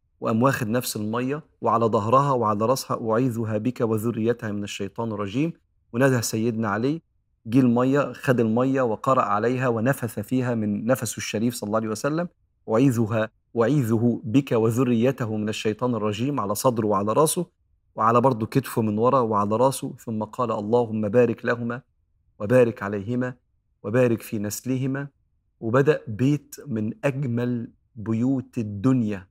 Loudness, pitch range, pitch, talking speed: -24 LUFS, 110-130 Hz, 115 Hz, 135 wpm